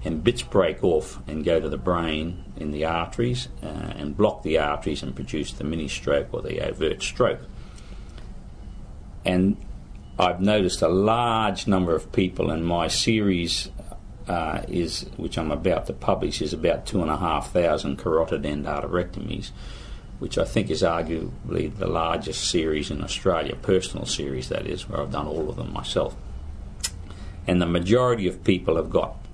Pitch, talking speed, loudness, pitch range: 90 Hz, 165 wpm, -25 LUFS, 80-100 Hz